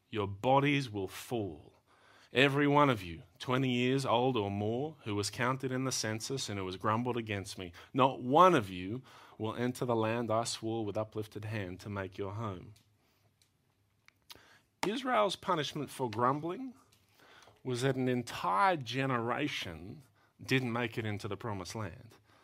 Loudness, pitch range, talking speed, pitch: -33 LUFS, 105-130 Hz, 155 wpm, 115 Hz